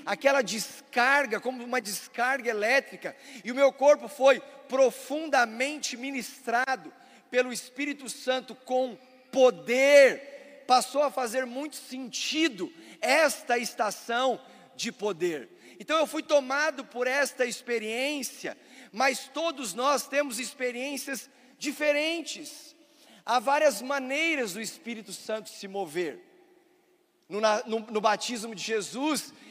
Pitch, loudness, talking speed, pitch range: 260 Hz, -27 LUFS, 110 wpm, 240-285 Hz